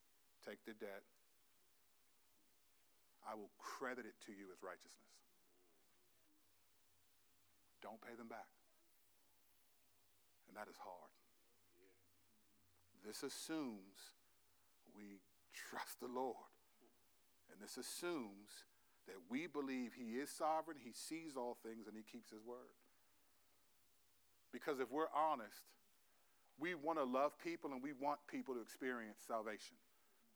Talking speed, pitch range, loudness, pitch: 115 wpm, 95-145 Hz, -49 LUFS, 110 Hz